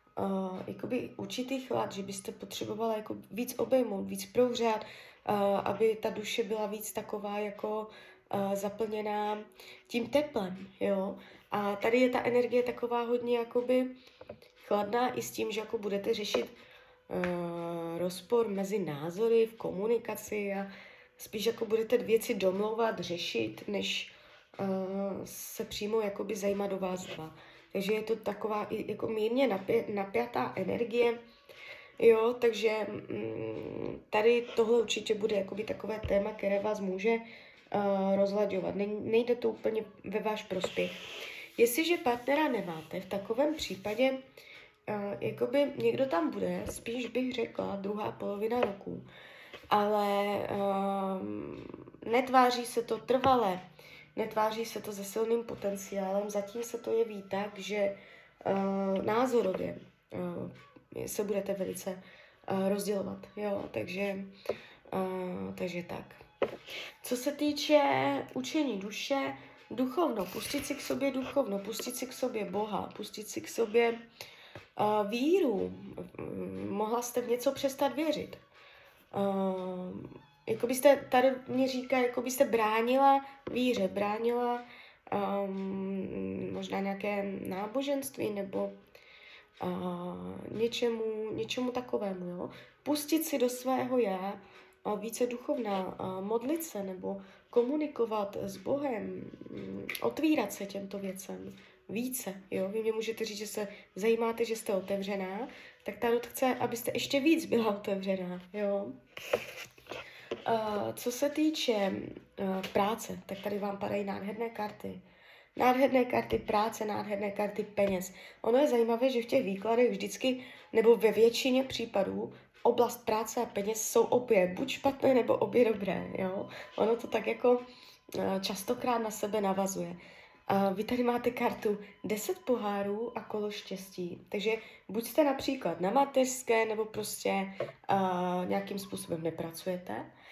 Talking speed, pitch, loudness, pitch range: 130 wpm, 215 Hz, -32 LUFS, 195-240 Hz